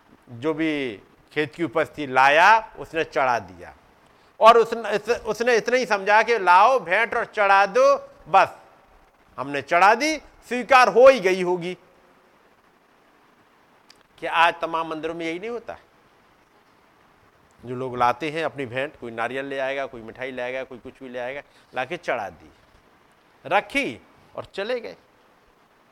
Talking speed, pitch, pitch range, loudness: 150 wpm, 165 Hz, 135-225 Hz, -21 LUFS